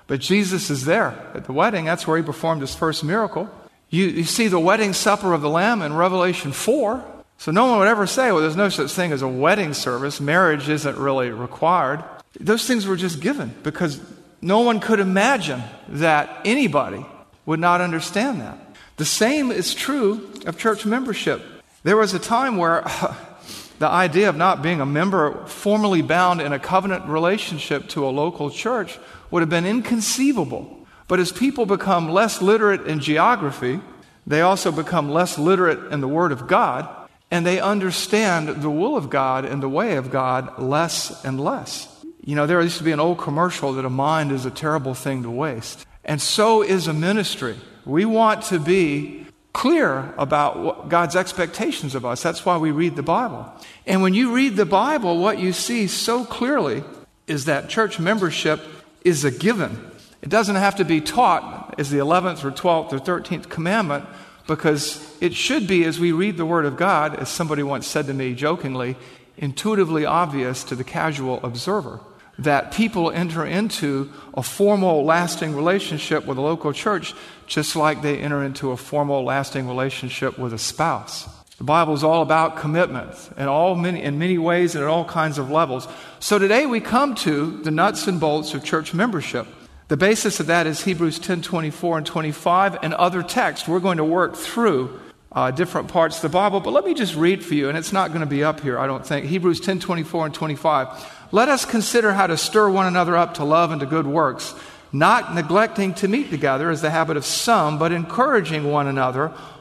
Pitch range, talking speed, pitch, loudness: 150-195 Hz, 195 wpm, 170 Hz, -20 LUFS